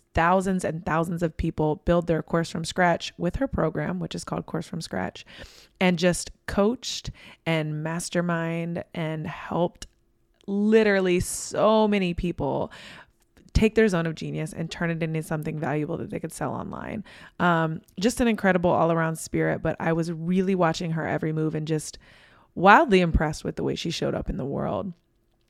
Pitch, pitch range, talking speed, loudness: 170 Hz, 160-185 Hz, 170 wpm, -25 LUFS